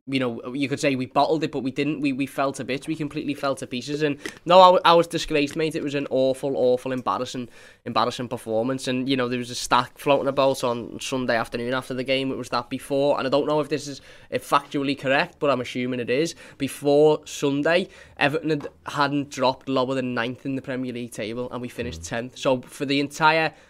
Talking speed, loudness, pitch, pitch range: 230 wpm, -23 LUFS, 135 Hz, 125-145 Hz